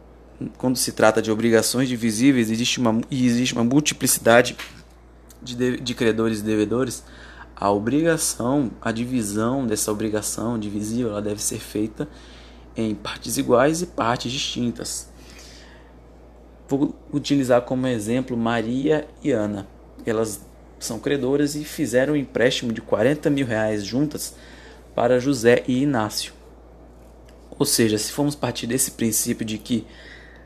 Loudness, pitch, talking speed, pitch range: -22 LUFS, 115 Hz, 130 wpm, 100-125 Hz